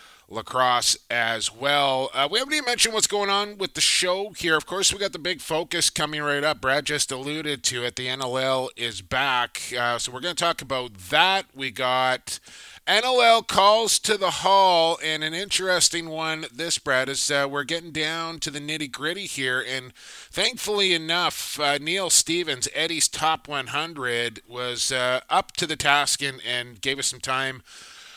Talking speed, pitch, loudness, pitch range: 185 wpm, 150 Hz, -23 LUFS, 130-170 Hz